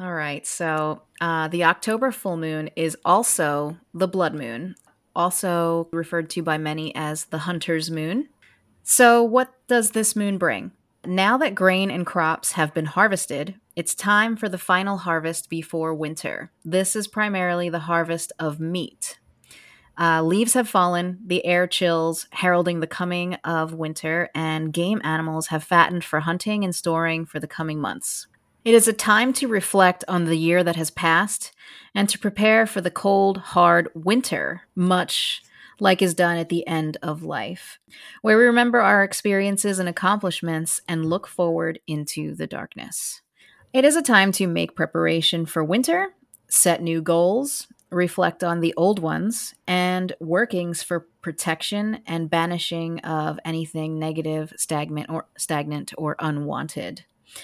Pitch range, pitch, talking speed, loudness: 160-195 Hz, 175 Hz, 155 wpm, -22 LUFS